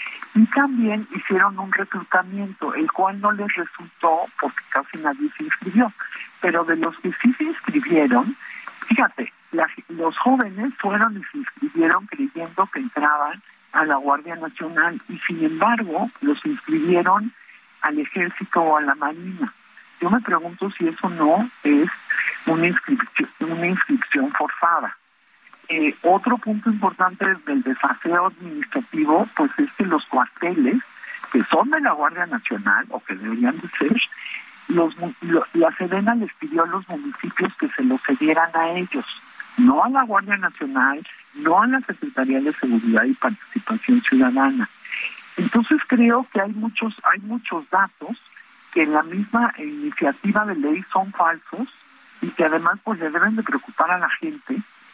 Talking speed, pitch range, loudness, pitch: 155 wpm, 175-270 Hz, -21 LUFS, 220 Hz